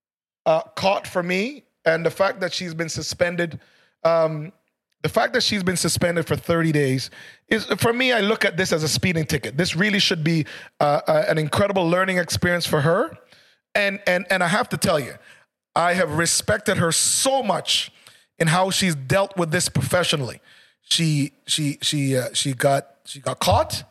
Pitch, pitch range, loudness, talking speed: 170 Hz, 155-190 Hz, -21 LUFS, 185 wpm